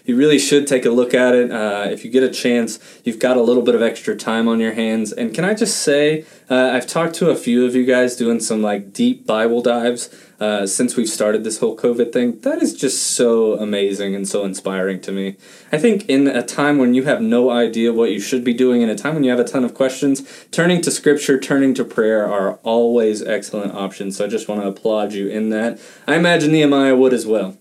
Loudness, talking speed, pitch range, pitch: -17 LUFS, 245 wpm, 110-140 Hz, 120 Hz